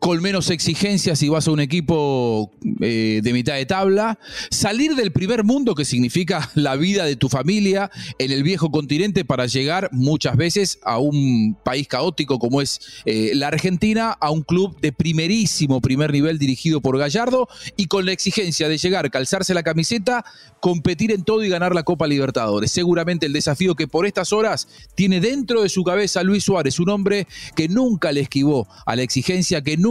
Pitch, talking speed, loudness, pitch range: 165 Hz, 185 wpm, -19 LUFS, 140-195 Hz